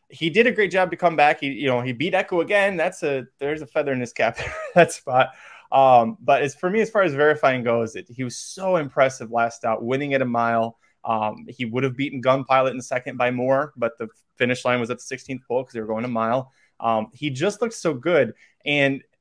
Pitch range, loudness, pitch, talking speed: 120-150 Hz, -22 LUFS, 130 Hz, 245 wpm